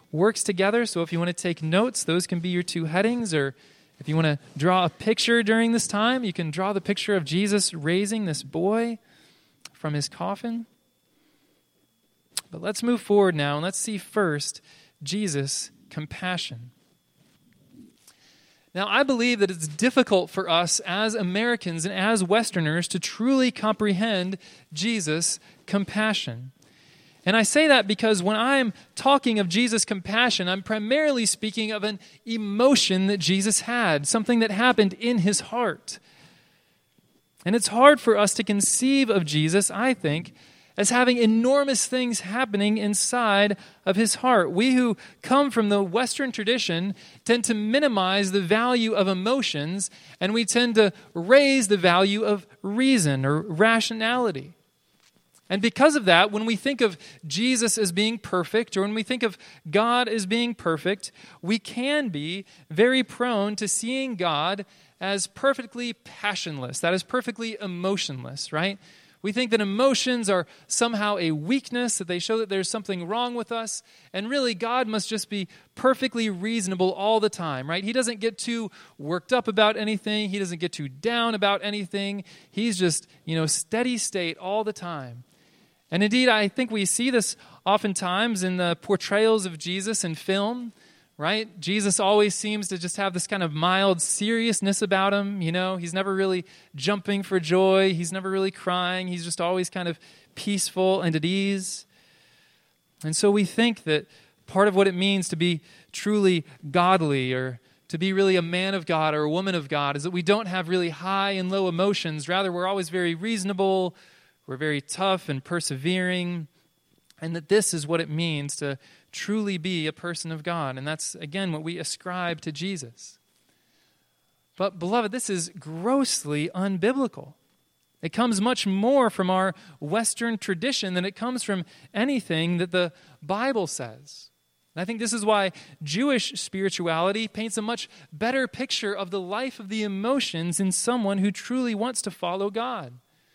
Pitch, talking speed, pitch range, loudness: 195 Hz, 165 wpm, 175-225 Hz, -24 LUFS